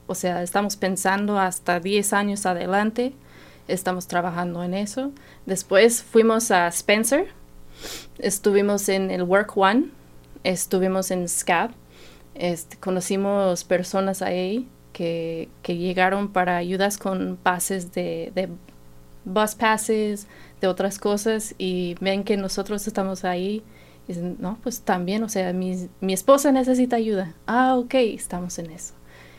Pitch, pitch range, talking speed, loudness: 190 Hz, 180-210 Hz, 135 wpm, -23 LUFS